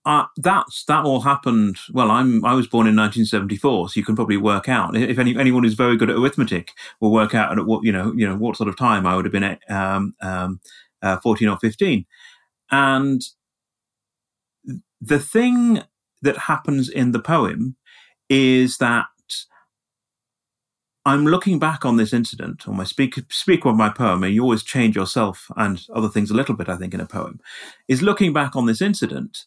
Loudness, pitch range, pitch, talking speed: -19 LUFS, 105-135 Hz, 120 Hz, 200 wpm